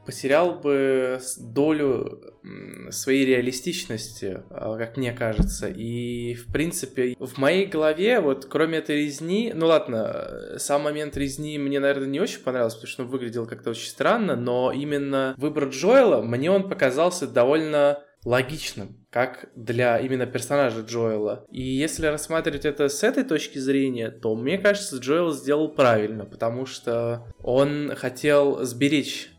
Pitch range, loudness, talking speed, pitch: 120-150 Hz, -24 LUFS, 140 wpm, 135 Hz